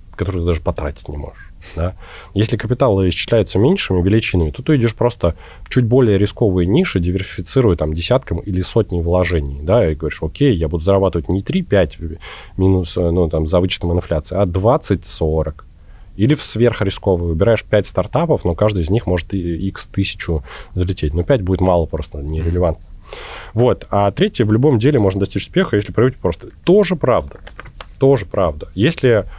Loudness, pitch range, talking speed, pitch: -17 LUFS, 85-115 Hz, 165 wpm, 95 Hz